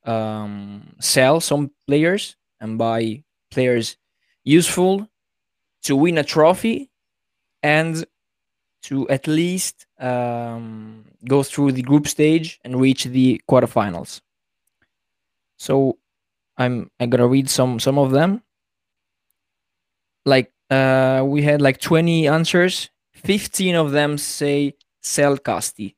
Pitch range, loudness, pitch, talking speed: 115-155 Hz, -19 LUFS, 135 Hz, 110 wpm